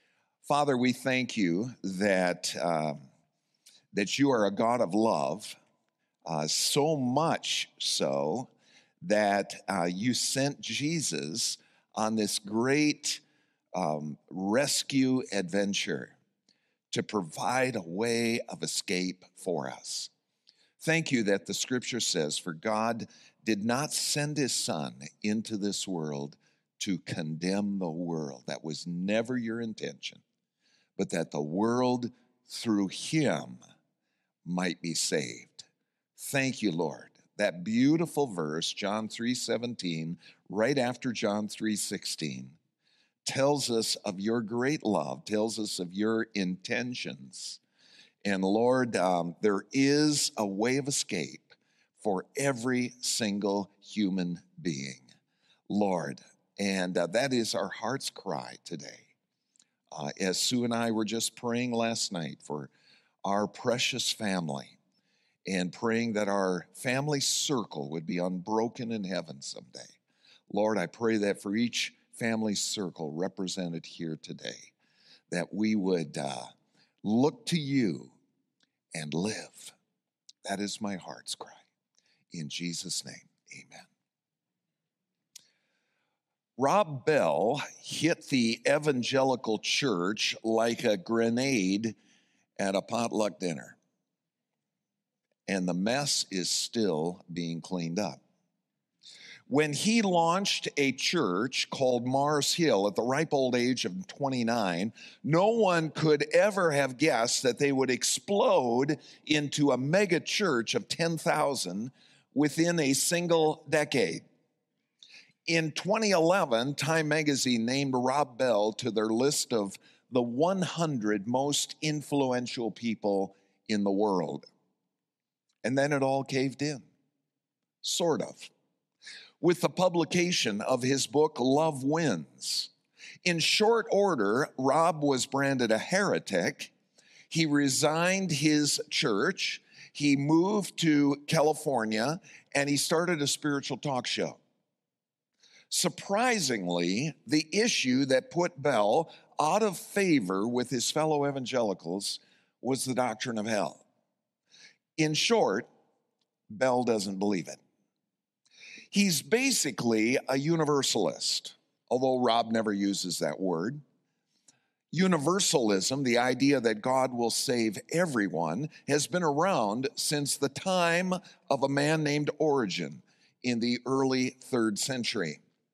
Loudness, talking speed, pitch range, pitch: -29 LUFS, 115 wpm, 100-145 Hz, 125 Hz